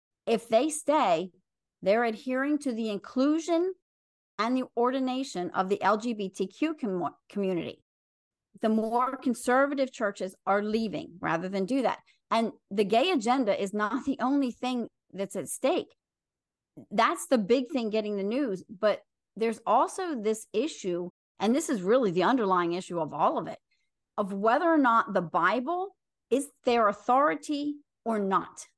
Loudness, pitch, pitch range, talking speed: -28 LUFS, 230 Hz, 200-265 Hz, 150 wpm